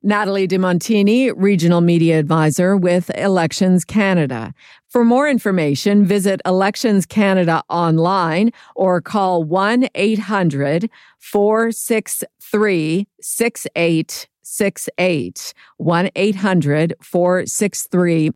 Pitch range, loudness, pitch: 170-210 Hz, -16 LUFS, 190 Hz